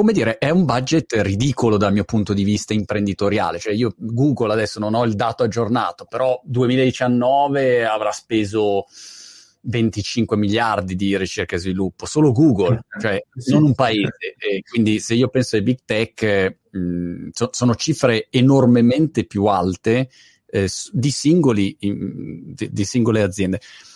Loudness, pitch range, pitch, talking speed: -19 LUFS, 105-130 Hz, 115 Hz, 145 wpm